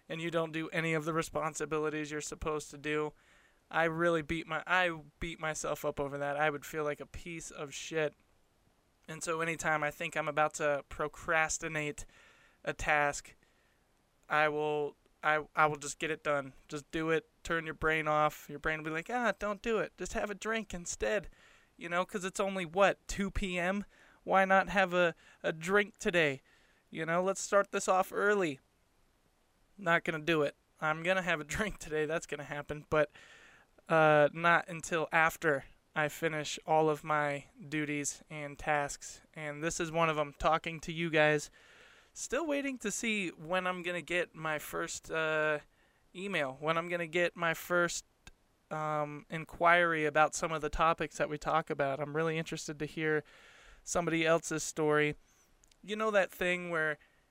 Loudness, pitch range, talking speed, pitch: -33 LUFS, 150-175 Hz, 185 wpm, 160 Hz